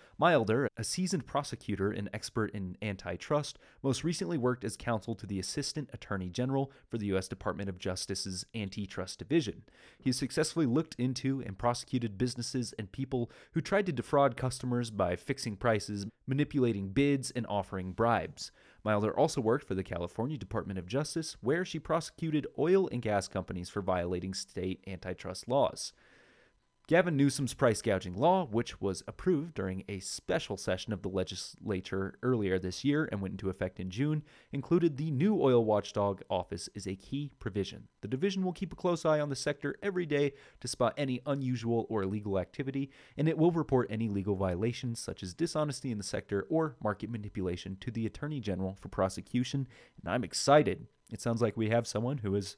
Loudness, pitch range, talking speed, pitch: -33 LUFS, 100-140 Hz, 175 wpm, 120 Hz